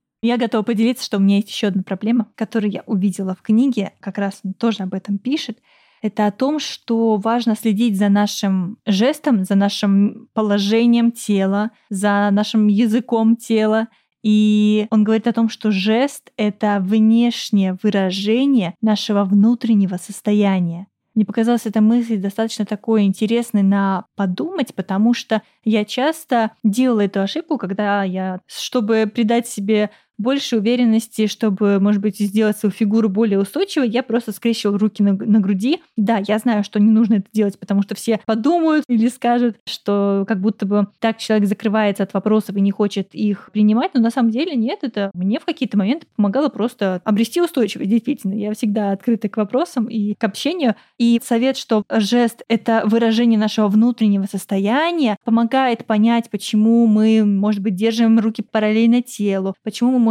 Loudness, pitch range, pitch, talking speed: -18 LUFS, 205-235 Hz, 220 Hz, 160 wpm